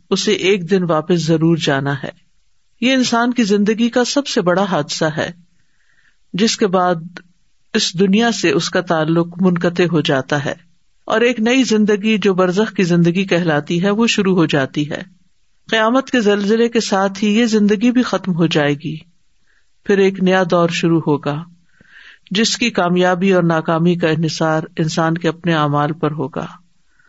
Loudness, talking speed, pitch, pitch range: -16 LUFS, 170 wpm, 180 Hz, 165-215 Hz